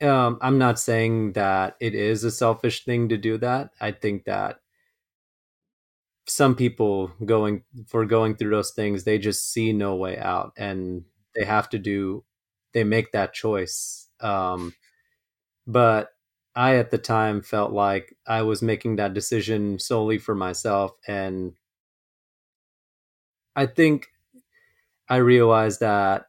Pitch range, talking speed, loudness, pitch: 100-120 Hz, 140 wpm, -23 LUFS, 110 Hz